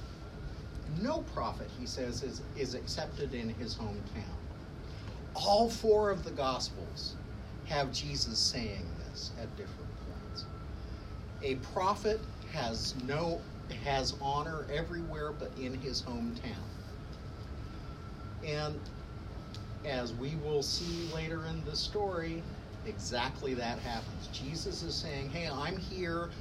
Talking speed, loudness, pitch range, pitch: 115 wpm, -37 LUFS, 105-150 Hz, 130 Hz